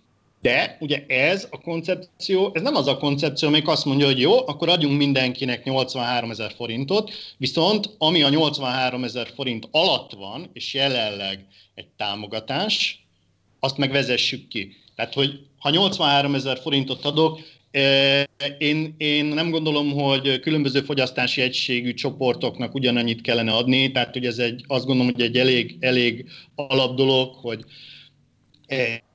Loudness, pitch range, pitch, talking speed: -21 LUFS, 125-145 Hz, 135 Hz, 145 wpm